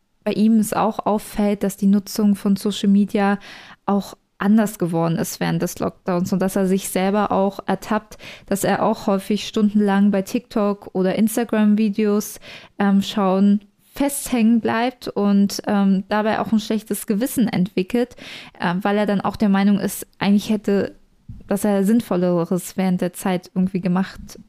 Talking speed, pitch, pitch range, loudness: 155 wpm, 205 Hz, 195-215 Hz, -20 LUFS